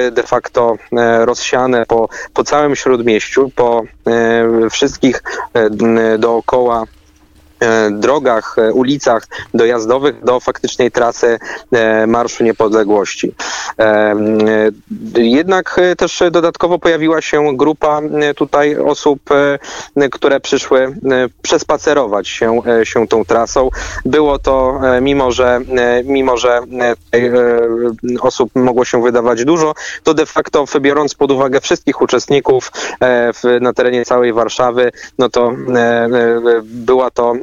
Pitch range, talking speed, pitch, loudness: 115-140 Hz, 105 wpm, 125 Hz, -13 LUFS